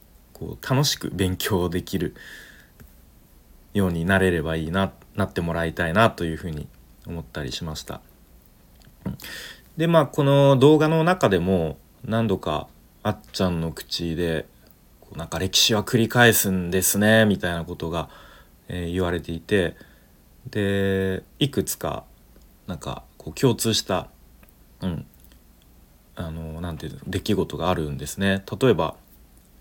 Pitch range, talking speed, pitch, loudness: 80-100 Hz, 265 characters per minute, 90 Hz, -23 LUFS